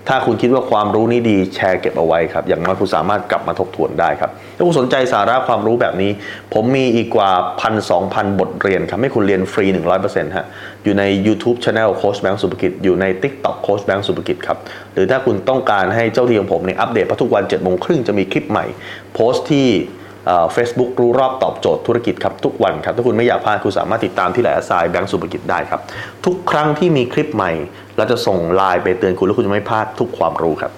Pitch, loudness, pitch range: 110 Hz, -16 LUFS, 95-120 Hz